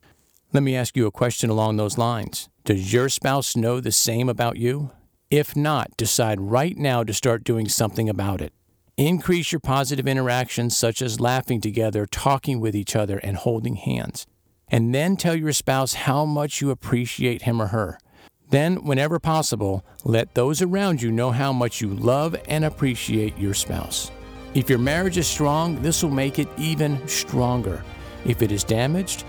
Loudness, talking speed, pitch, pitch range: -22 LUFS, 175 wpm, 125 Hz, 110-140 Hz